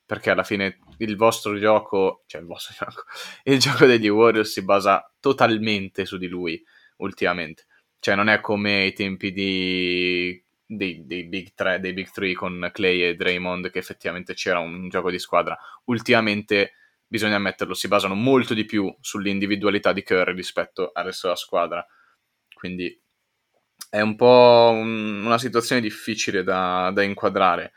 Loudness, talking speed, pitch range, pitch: -21 LUFS, 155 wpm, 90-110 Hz, 100 Hz